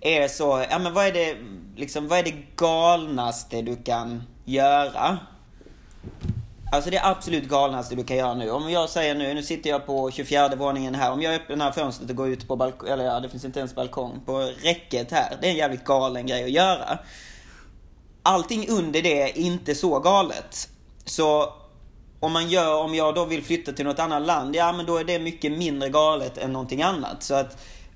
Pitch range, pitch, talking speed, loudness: 130-165 Hz, 145 Hz, 205 wpm, -24 LUFS